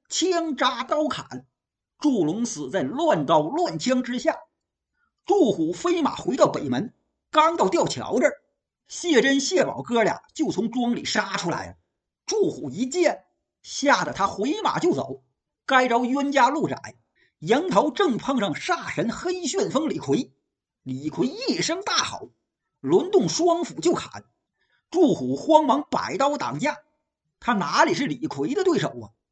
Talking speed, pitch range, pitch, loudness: 205 characters per minute, 250-345 Hz, 305 Hz, -23 LUFS